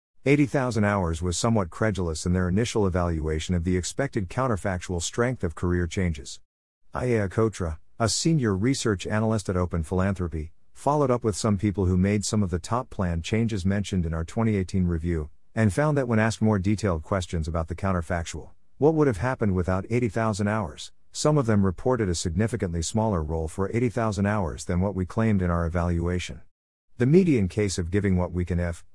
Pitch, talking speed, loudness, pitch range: 95 Hz, 185 wpm, -25 LUFS, 85-110 Hz